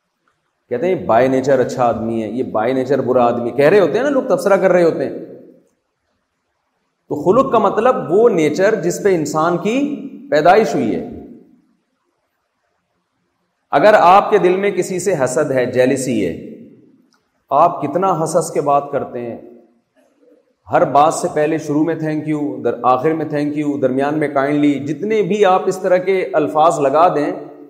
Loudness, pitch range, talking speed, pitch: -15 LUFS, 130-185 Hz, 170 wpm, 155 Hz